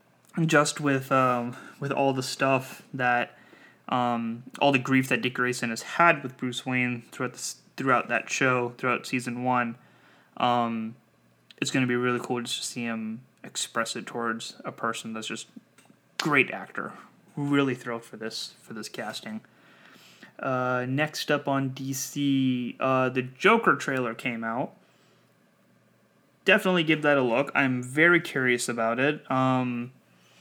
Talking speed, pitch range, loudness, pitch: 150 wpm, 120-135 Hz, -26 LUFS, 125 Hz